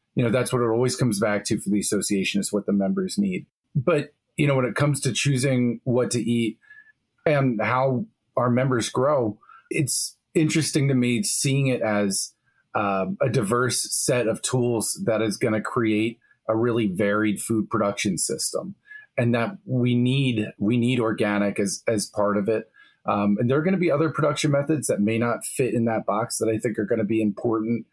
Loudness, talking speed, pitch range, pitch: -23 LUFS, 200 wpm, 110-135 Hz, 120 Hz